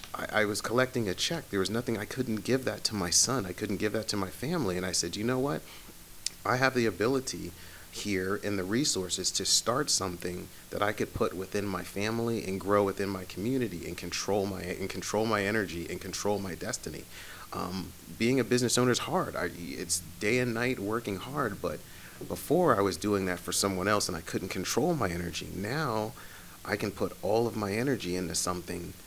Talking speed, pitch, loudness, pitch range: 210 wpm, 100 Hz, -30 LUFS, 90-115 Hz